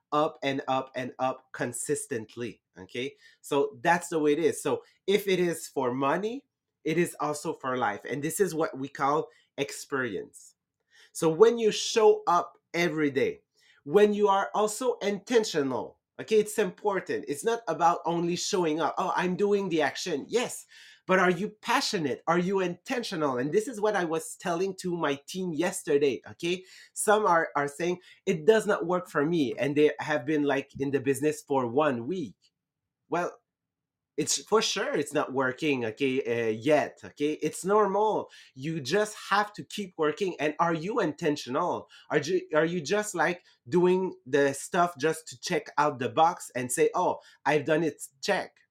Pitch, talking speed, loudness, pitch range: 165 Hz, 175 wpm, -28 LUFS, 145-205 Hz